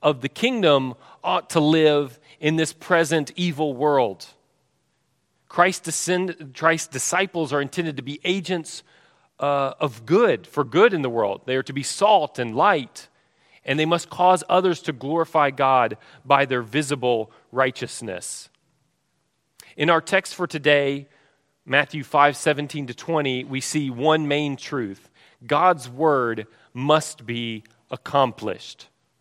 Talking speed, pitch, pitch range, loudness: 130 wpm, 150 Hz, 135-165 Hz, -22 LUFS